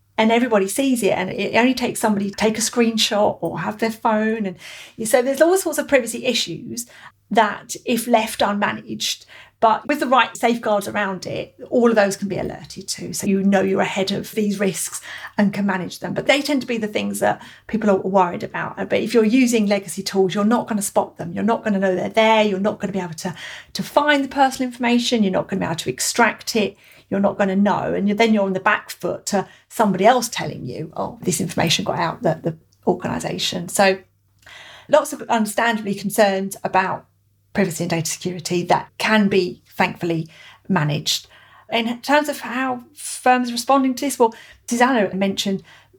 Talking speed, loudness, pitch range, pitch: 205 wpm, -20 LUFS, 190-235 Hz, 205 Hz